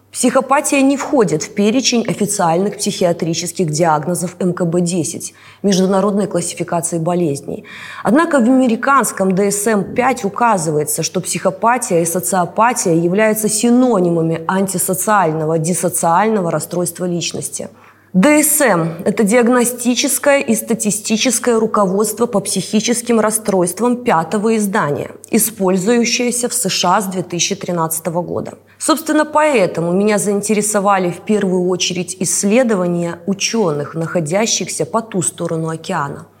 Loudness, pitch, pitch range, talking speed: -15 LUFS, 195 Hz, 175-225 Hz, 95 wpm